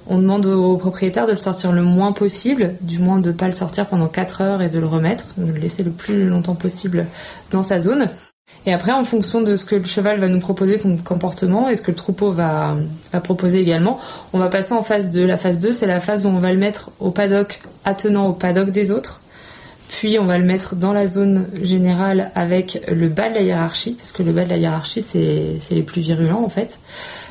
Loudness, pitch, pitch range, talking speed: -18 LUFS, 185 Hz, 180-205 Hz, 240 wpm